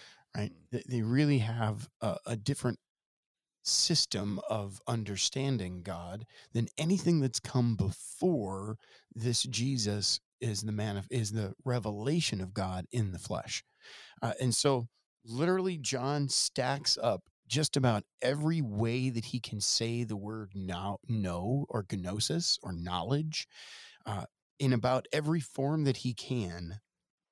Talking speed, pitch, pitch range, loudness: 135 wpm, 120 Hz, 105-135 Hz, -33 LUFS